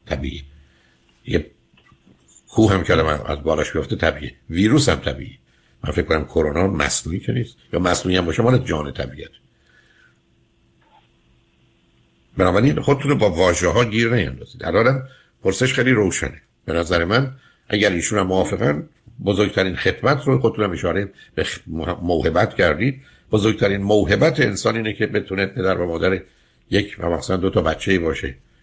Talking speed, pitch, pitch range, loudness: 150 wpm, 95 Hz, 80-115 Hz, -19 LUFS